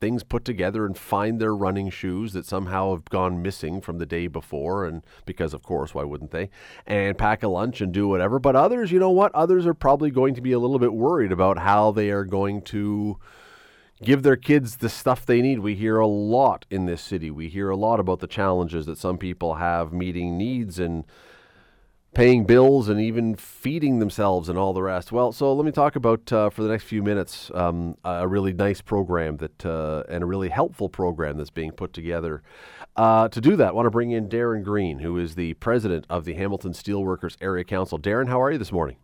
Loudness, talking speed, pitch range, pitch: -23 LUFS, 225 wpm, 90-115 Hz, 100 Hz